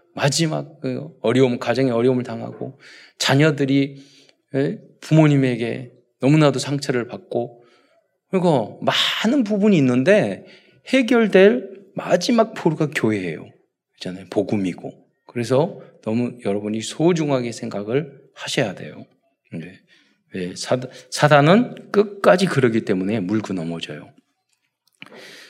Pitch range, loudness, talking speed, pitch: 120-175 Hz, -19 LUFS, 245 characters per minute, 135 Hz